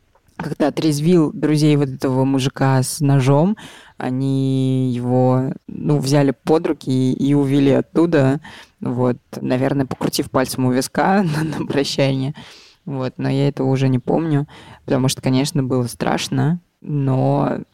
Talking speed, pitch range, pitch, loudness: 130 wpm, 130-150 Hz, 140 Hz, -18 LUFS